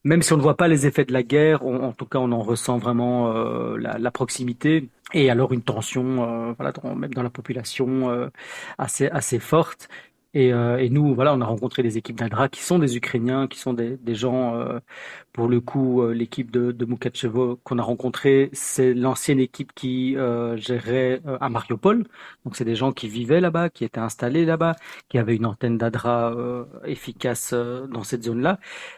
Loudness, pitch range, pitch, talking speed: -23 LUFS, 120-135 Hz, 125 Hz, 210 wpm